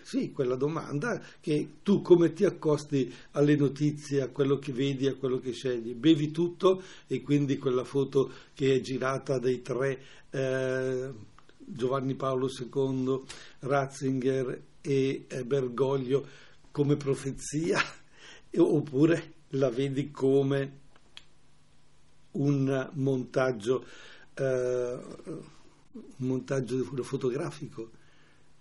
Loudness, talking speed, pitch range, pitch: -29 LUFS, 105 wpm, 130-145 Hz, 135 Hz